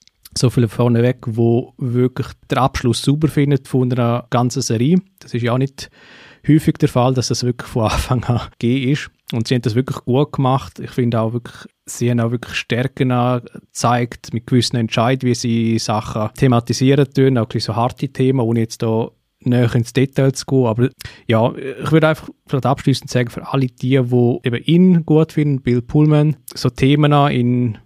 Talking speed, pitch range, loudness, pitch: 190 wpm, 120-135 Hz, -17 LUFS, 125 Hz